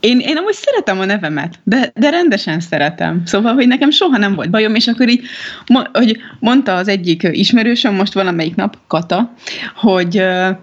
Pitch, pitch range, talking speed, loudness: 215 Hz, 185-250 Hz, 170 wpm, -13 LUFS